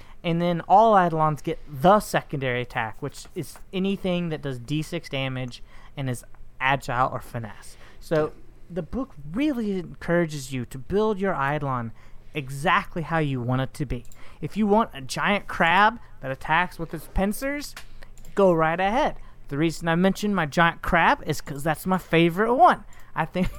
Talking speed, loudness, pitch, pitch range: 170 wpm, -24 LUFS, 160 Hz, 135-185 Hz